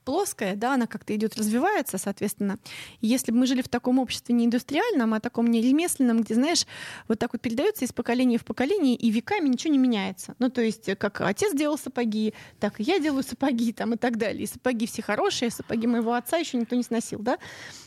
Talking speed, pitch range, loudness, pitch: 210 wpm, 225-260 Hz, -26 LUFS, 240 Hz